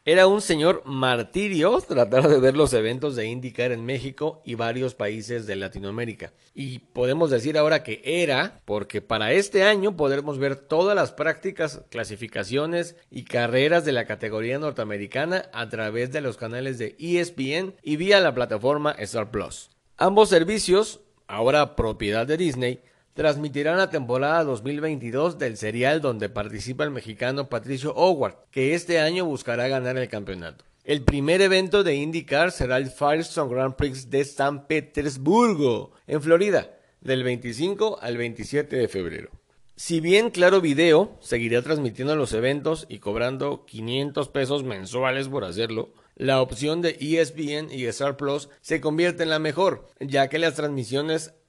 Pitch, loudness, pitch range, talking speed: 140 Hz, -24 LUFS, 120-160 Hz, 150 wpm